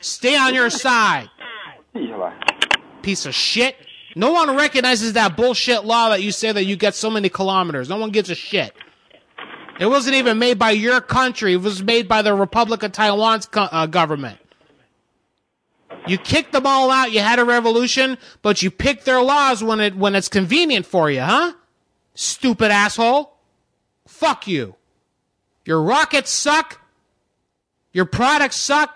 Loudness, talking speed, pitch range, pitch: -17 LUFS, 160 wpm, 195-265 Hz, 225 Hz